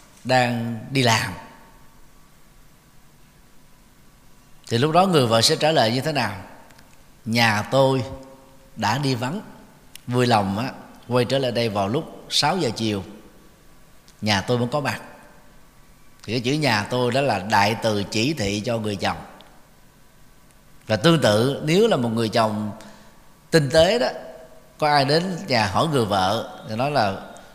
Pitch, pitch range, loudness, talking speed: 125 Hz, 110-140 Hz, -21 LUFS, 155 wpm